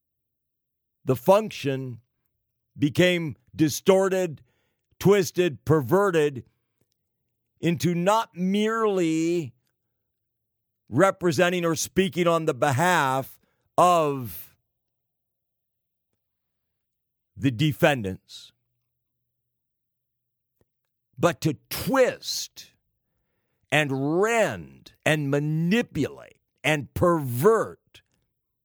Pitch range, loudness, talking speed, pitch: 120-170 Hz, -24 LUFS, 55 wpm, 140 Hz